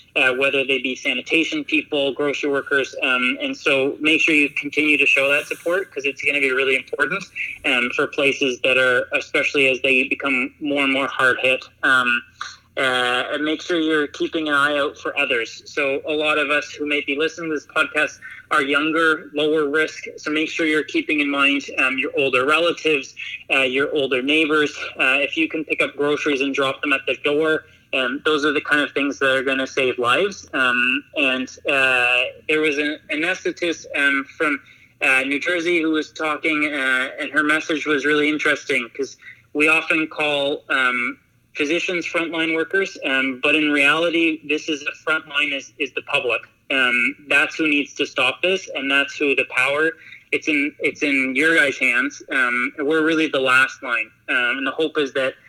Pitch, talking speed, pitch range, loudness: 150 Hz, 195 wpm, 140-160 Hz, -19 LUFS